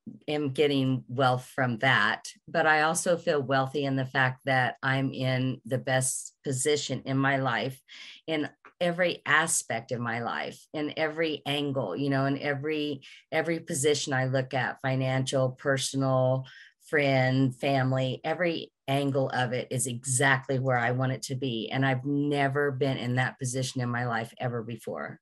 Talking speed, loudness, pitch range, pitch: 160 wpm, -28 LUFS, 130-145 Hz, 135 Hz